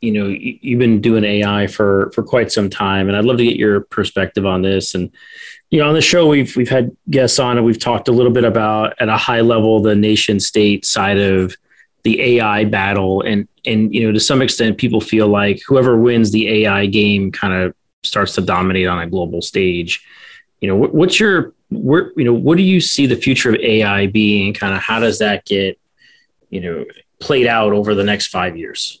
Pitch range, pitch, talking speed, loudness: 100-120 Hz, 110 Hz, 220 wpm, -14 LUFS